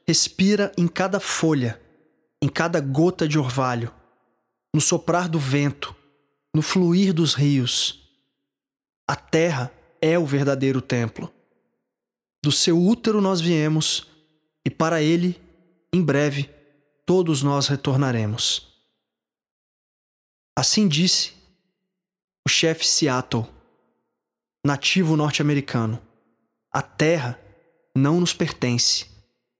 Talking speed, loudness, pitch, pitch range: 95 wpm, -21 LUFS, 155 Hz, 130-170 Hz